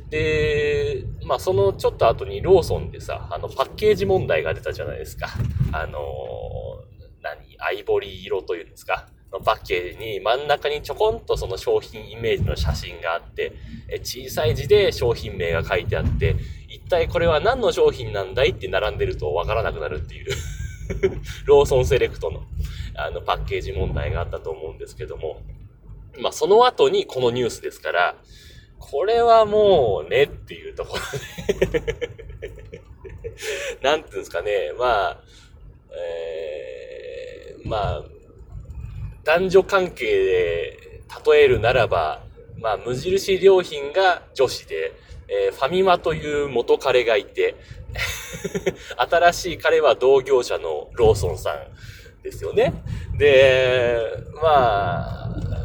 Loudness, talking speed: -21 LUFS, 285 characters per minute